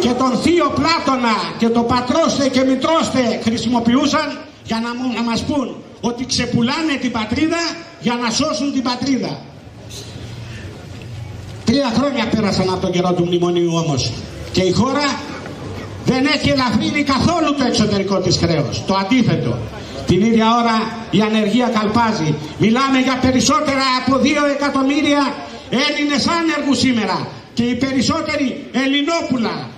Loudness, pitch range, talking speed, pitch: -17 LUFS, 190-275 Hz, 130 wpm, 245 Hz